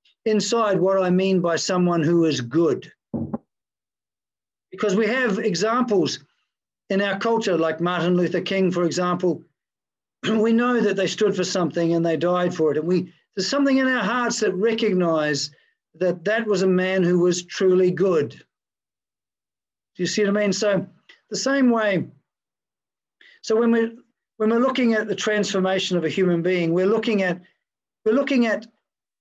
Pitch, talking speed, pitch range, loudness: 190 Hz, 165 wpm, 175-220 Hz, -21 LUFS